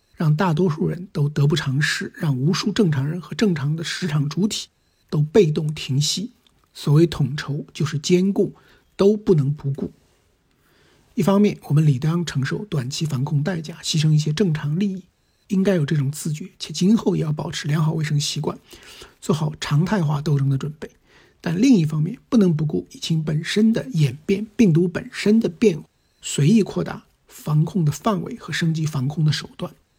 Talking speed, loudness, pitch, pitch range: 270 characters per minute, -21 LUFS, 165 Hz, 150-195 Hz